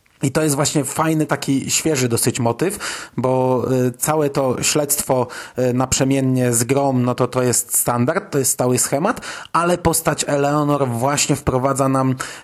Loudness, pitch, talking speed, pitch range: -18 LUFS, 135 Hz, 150 wpm, 125-150 Hz